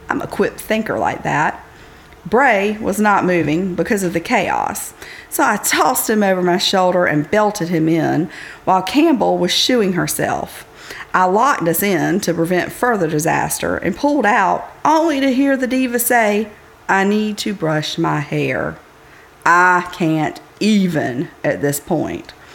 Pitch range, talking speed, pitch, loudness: 165-220 Hz, 155 wpm, 185 Hz, -16 LUFS